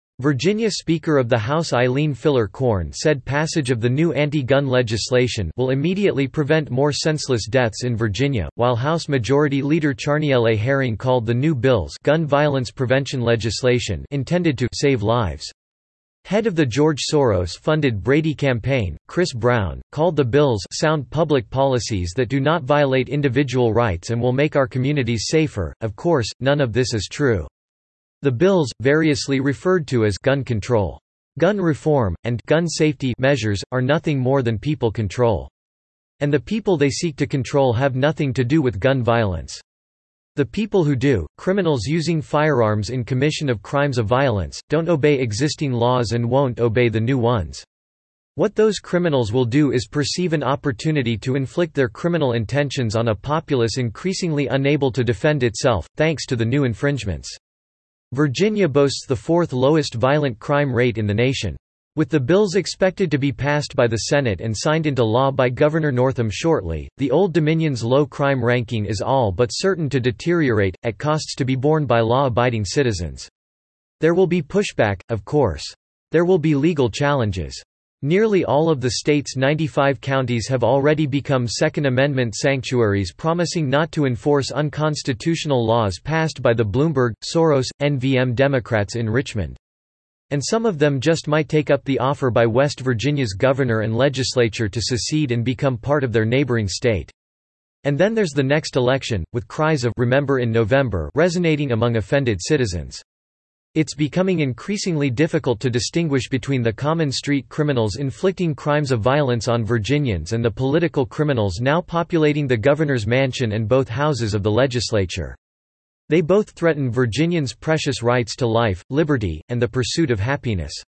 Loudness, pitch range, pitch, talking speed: -20 LUFS, 115-150 Hz, 135 Hz, 165 wpm